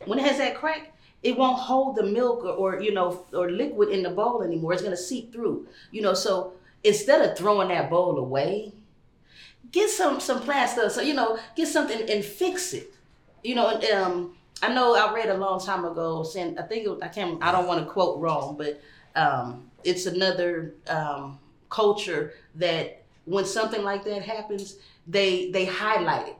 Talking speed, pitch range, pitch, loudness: 195 wpm, 175-230 Hz, 200 Hz, -25 LUFS